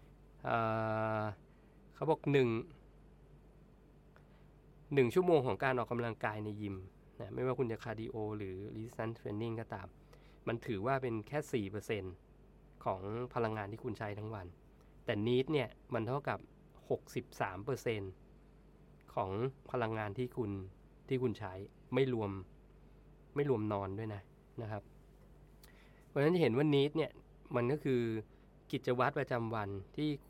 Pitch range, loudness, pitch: 105-135 Hz, -37 LUFS, 115 Hz